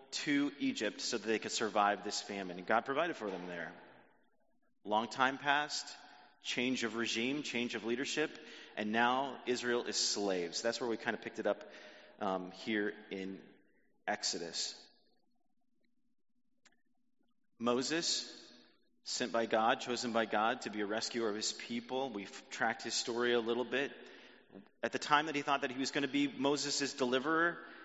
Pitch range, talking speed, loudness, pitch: 110-145 Hz, 165 wpm, -36 LUFS, 125 Hz